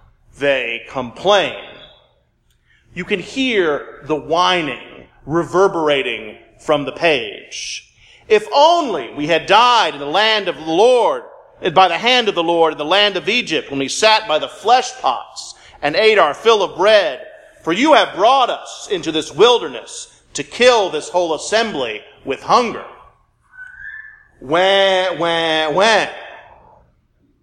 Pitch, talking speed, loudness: 205 Hz, 140 wpm, -15 LUFS